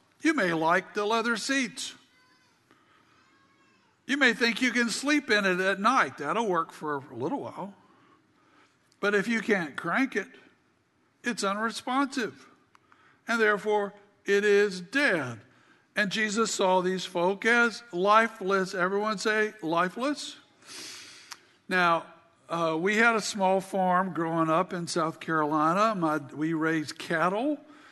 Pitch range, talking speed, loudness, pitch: 175-235 Hz, 130 wpm, -27 LUFS, 205 Hz